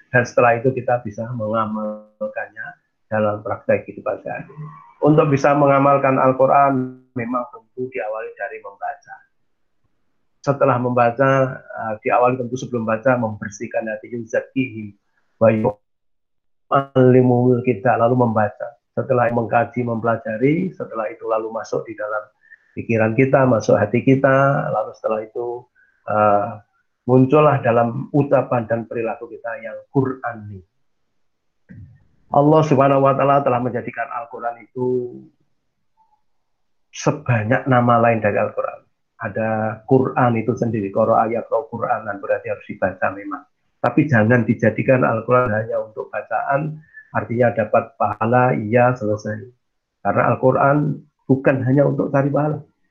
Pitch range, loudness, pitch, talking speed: 110-135 Hz, -19 LUFS, 125 Hz, 120 wpm